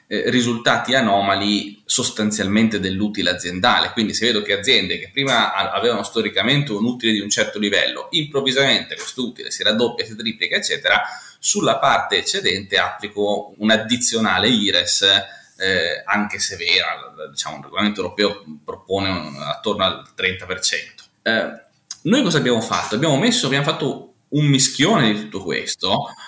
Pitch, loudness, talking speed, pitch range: 110 Hz, -18 LUFS, 140 wpm, 100-125 Hz